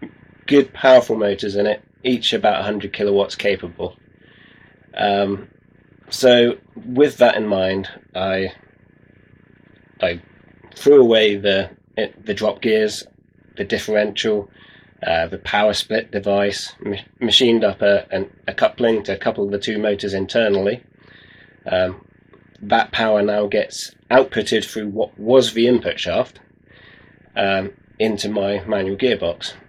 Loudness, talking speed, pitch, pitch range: -18 LUFS, 125 wpm, 105 Hz, 100-115 Hz